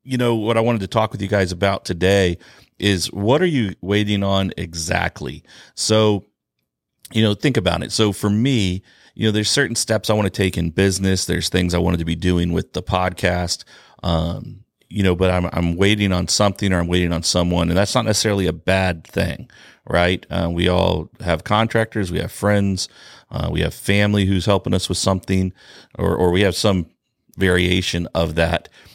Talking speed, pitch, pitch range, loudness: 200 wpm, 95 Hz, 90-105 Hz, -19 LUFS